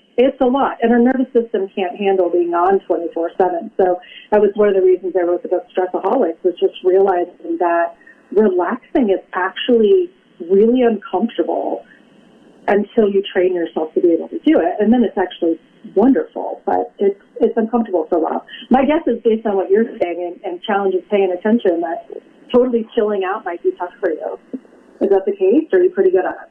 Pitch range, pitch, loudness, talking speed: 180-245 Hz, 205 Hz, -17 LUFS, 195 wpm